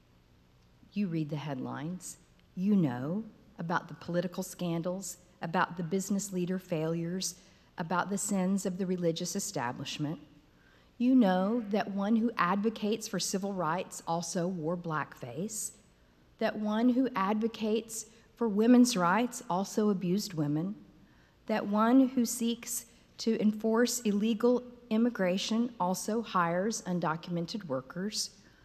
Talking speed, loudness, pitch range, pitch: 115 wpm, -31 LUFS, 175-220 Hz, 190 Hz